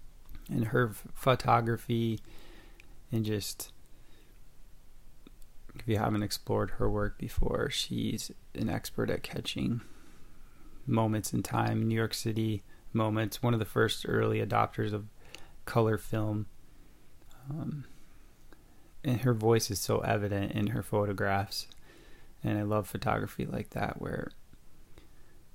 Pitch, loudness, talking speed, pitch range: 110 Hz, -32 LUFS, 115 wpm, 105-115 Hz